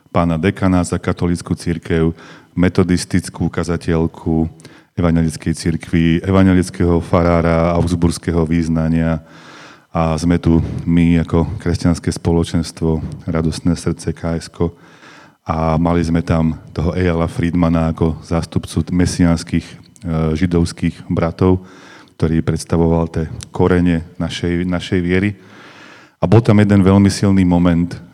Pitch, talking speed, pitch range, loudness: 85 Hz, 105 wpm, 80-90 Hz, -16 LUFS